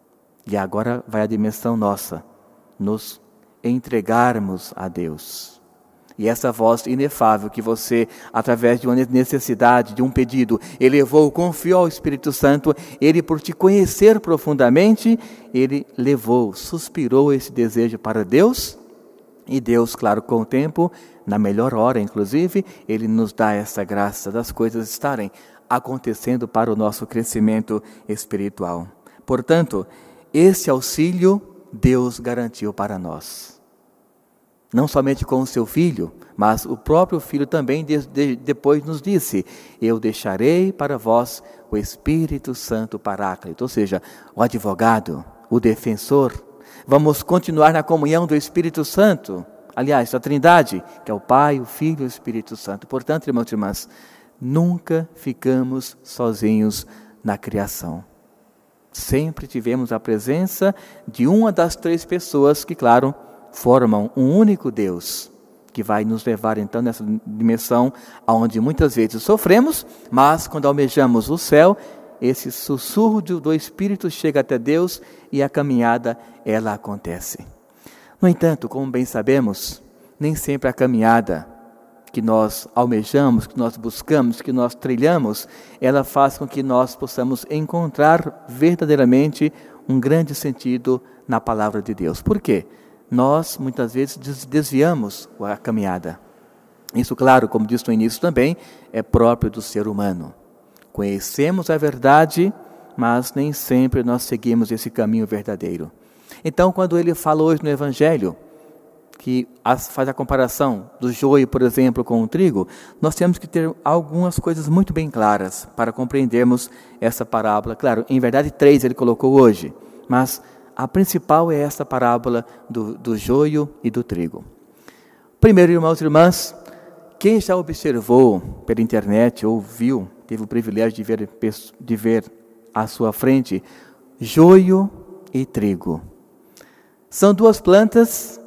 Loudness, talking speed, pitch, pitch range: -18 LUFS, 135 wpm, 130 Hz, 115-155 Hz